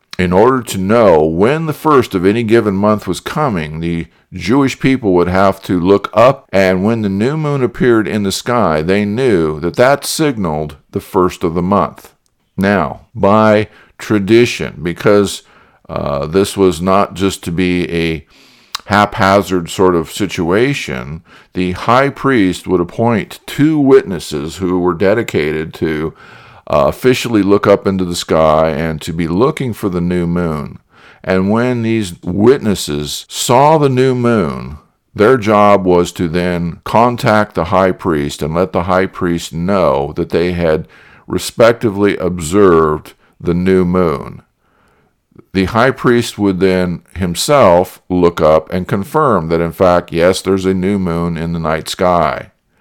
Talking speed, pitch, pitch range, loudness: 155 wpm, 95 Hz, 85-105 Hz, -13 LUFS